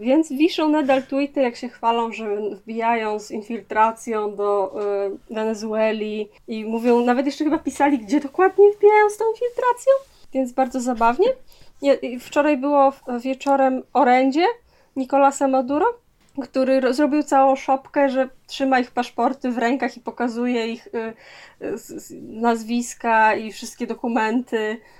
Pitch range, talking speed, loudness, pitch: 230-285 Hz, 140 wpm, -21 LUFS, 255 Hz